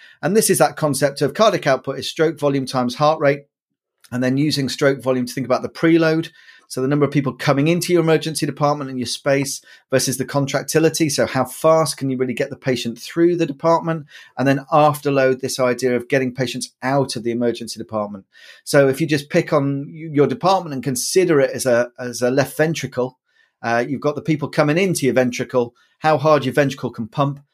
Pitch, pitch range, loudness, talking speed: 140 Hz, 130-155 Hz, -19 LUFS, 210 wpm